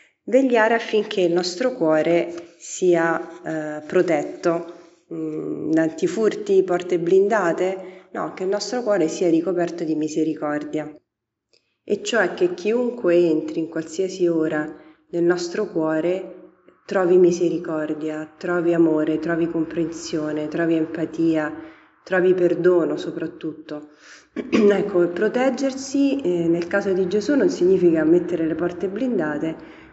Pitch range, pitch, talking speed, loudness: 160-195 Hz, 175 Hz, 110 wpm, -21 LUFS